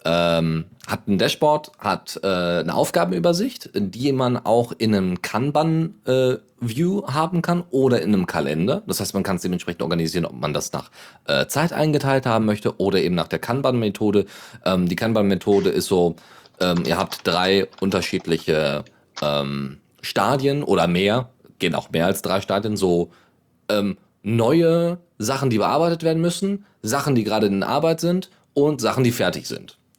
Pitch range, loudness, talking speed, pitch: 95-150 Hz, -21 LUFS, 165 wpm, 115 Hz